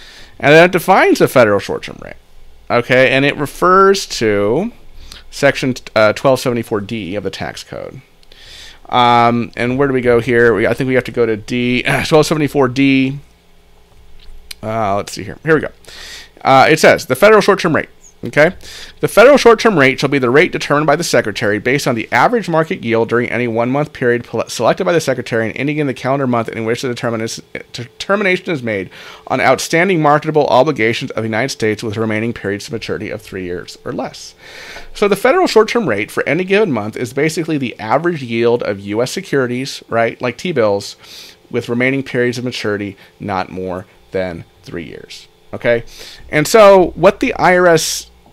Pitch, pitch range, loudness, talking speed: 125 Hz, 115-150 Hz, -14 LUFS, 185 wpm